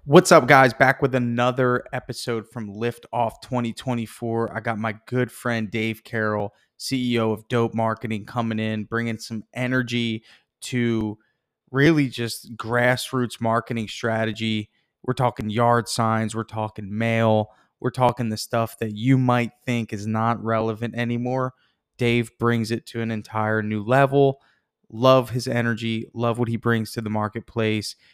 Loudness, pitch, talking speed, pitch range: -23 LUFS, 115 Hz, 150 wpm, 110-125 Hz